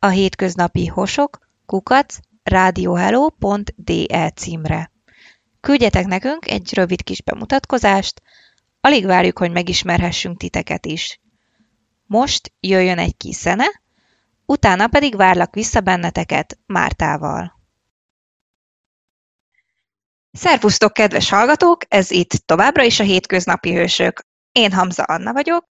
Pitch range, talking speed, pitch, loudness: 180-265 Hz, 100 wpm, 200 Hz, -16 LUFS